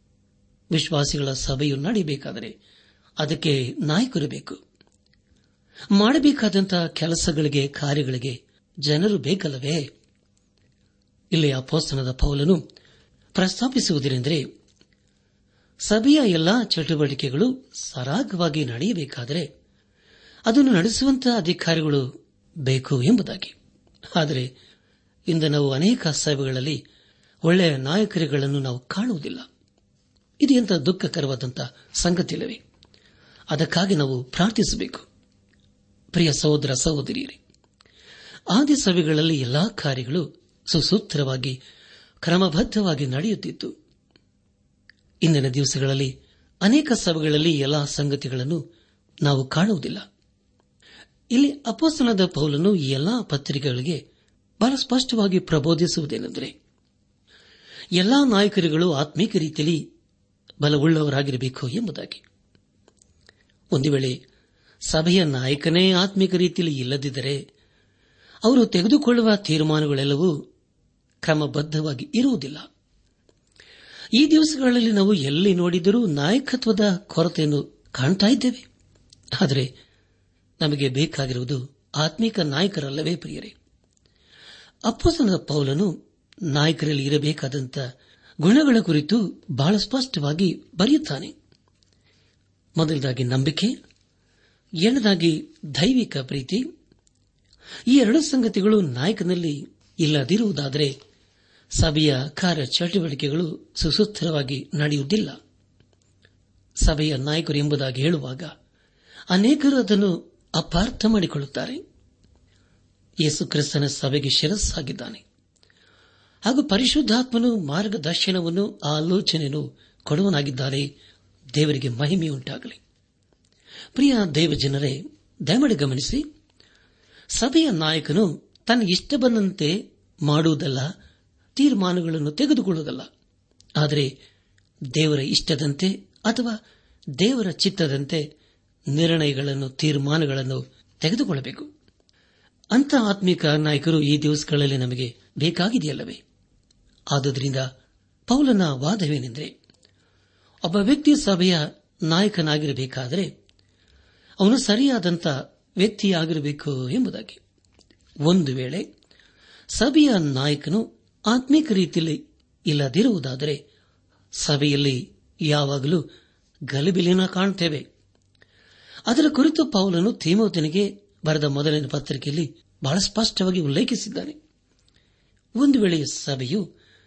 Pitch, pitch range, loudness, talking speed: 155 Hz, 140-195 Hz, -22 LUFS, 70 wpm